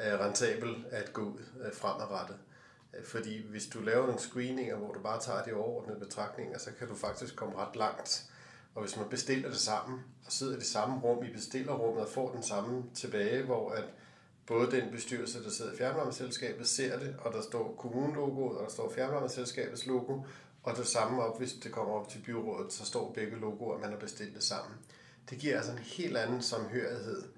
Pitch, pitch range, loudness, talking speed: 120 Hz, 110-130 Hz, -36 LUFS, 200 wpm